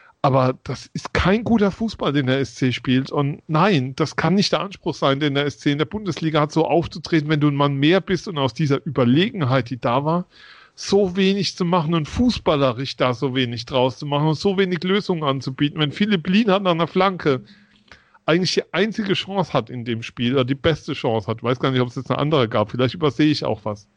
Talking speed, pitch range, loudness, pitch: 230 wpm, 135-180 Hz, -20 LUFS, 150 Hz